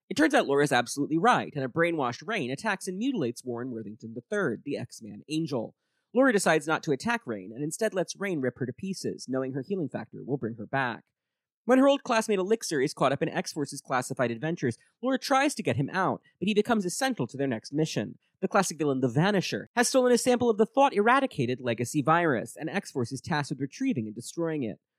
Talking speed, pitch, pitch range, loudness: 220 wpm, 155 Hz, 130-220 Hz, -28 LUFS